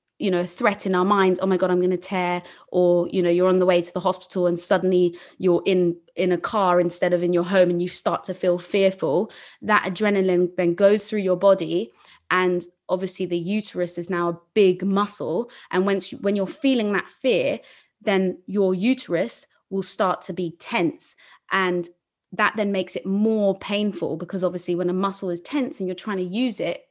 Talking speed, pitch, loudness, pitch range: 205 wpm, 185 Hz, -22 LUFS, 180-200 Hz